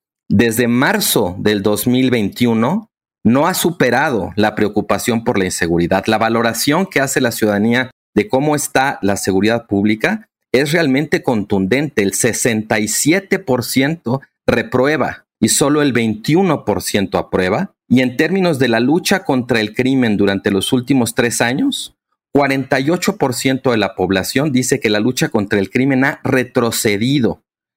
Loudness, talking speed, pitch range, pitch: -15 LUFS, 135 wpm, 105-140 Hz, 125 Hz